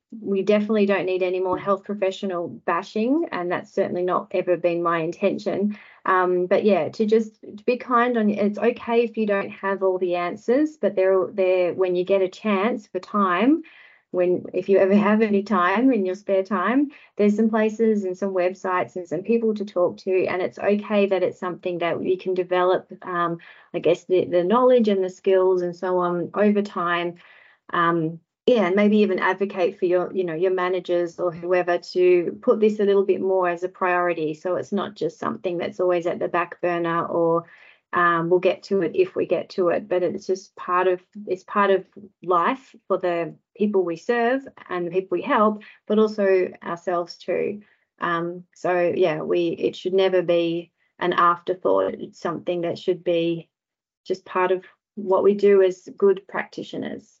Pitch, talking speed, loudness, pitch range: 190 Hz, 195 wpm, -22 LUFS, 180-210 Hz